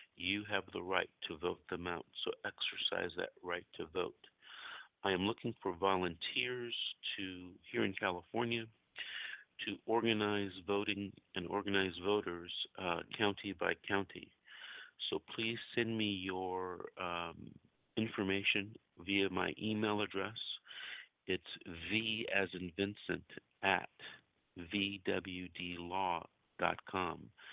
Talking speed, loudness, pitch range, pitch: 110 wpm, -39 LUFS, 95-110 Hz, 100 Hz